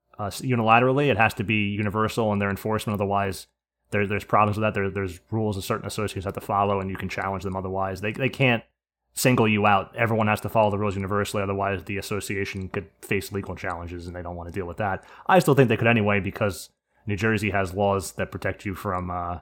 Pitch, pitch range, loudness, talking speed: 100 Hz, 95-110 Hz, -24 LUFS, 230 wpm